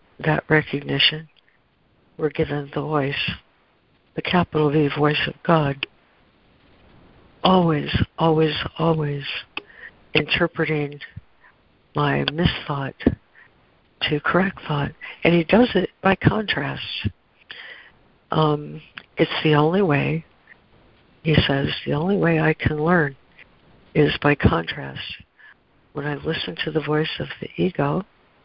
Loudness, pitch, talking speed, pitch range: -21 LUFS, 155 Hz, 110 wpm, 145-165 Hz